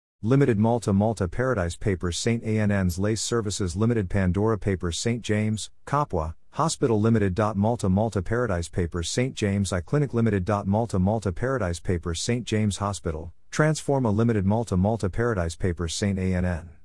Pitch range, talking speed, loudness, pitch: 90-115 Hz, 145 wpm, -25 LUFS, 105 Hz